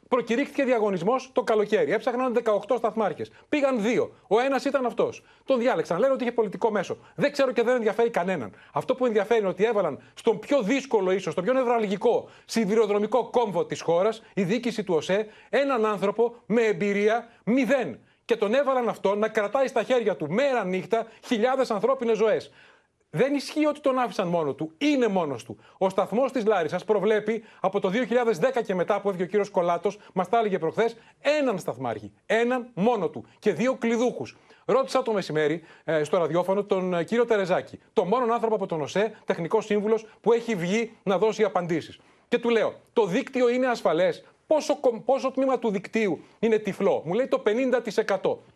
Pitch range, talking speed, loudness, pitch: 200-255 Hz, 175 wpm, -25 LUFS, 225 Hz